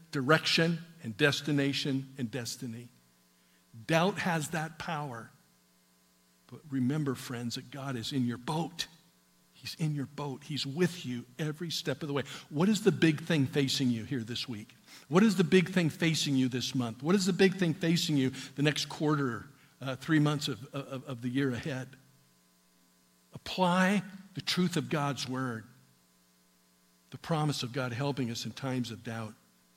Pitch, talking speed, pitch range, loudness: 135 Hz, 170 wpm, 115-155 Hz, -31 LUFS